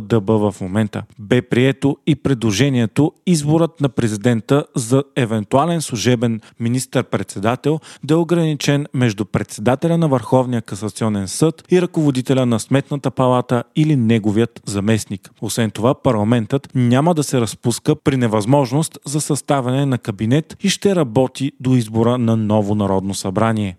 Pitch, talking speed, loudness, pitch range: 125 Hz, 135 wpm, -18 LUFS, 115-145 Hz